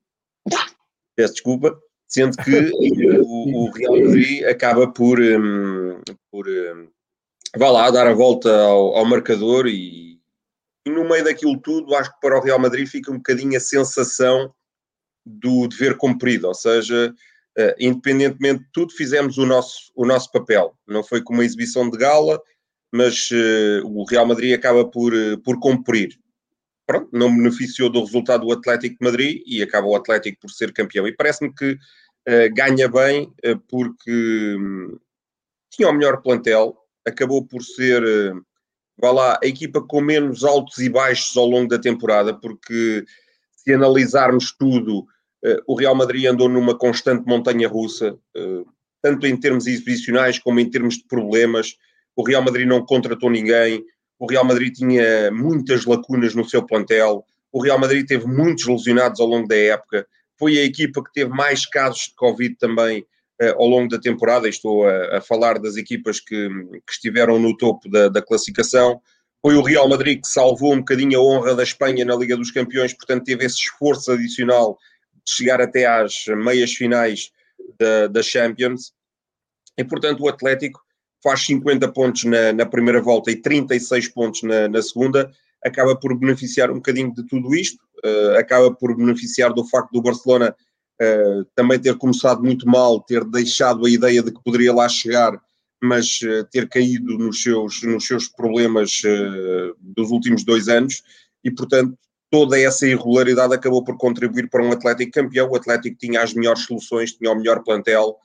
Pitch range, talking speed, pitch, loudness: 115-130 Hz, 165 wpm, 125 Hz, -17 LUFS